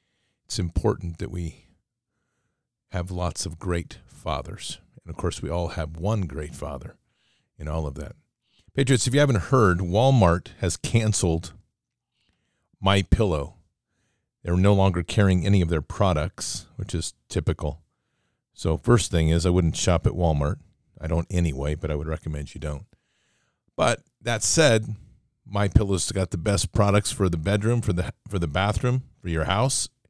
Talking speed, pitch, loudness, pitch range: 160 wpm, 95 Hz, -24 LUFS, 85-110 Hz